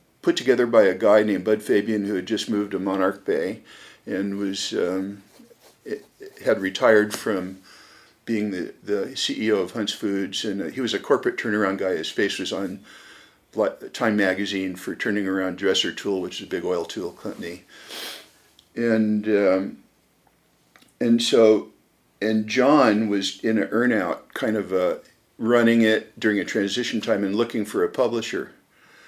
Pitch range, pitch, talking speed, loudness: 95-110 Hz, 105 Hz, 160 wpm, -23 LUFS